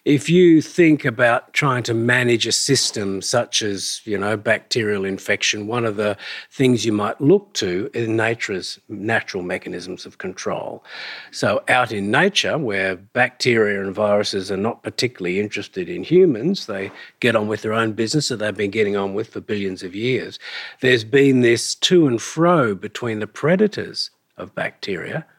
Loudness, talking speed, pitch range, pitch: -19 LUFS, 175 wpm, 105-140 Hz, 115 Hz